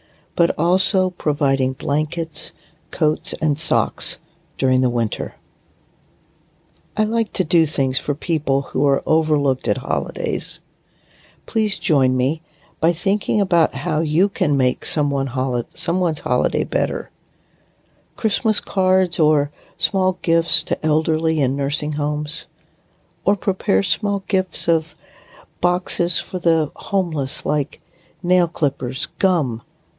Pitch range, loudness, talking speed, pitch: 145-180 Hz, -20 LUFS, 115 wpm, 160 Hz